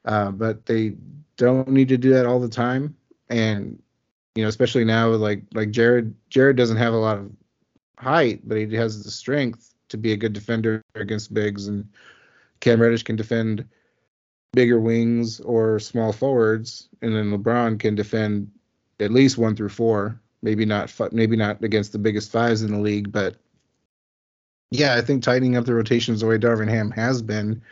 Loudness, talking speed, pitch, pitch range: -21 LUFS, 180 wpm, 115 Hz, 110-120 Hz